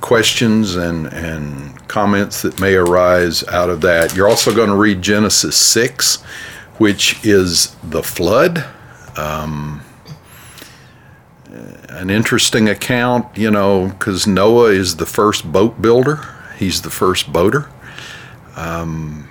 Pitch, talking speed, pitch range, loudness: 100 Hz, 120 wpm, 80-110 Hz, -14 LUFS